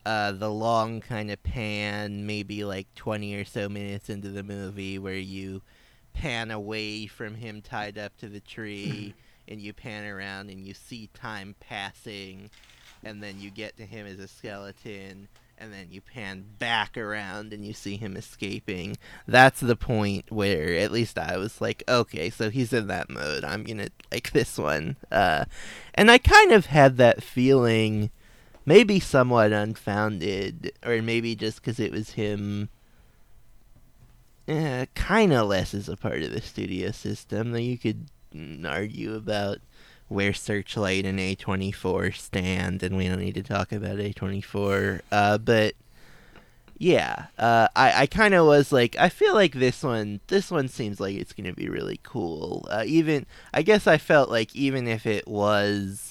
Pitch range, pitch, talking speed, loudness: 100-120 Hz, 105 Hz, 165 wpm, -24 LUFS